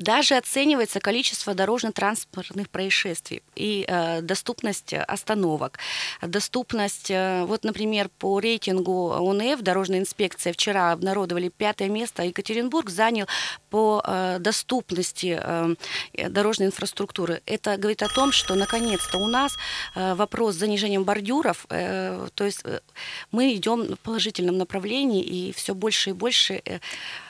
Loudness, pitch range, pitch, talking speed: -24 LUFS, 185-220 Hz, 200 Hz, 130 wpm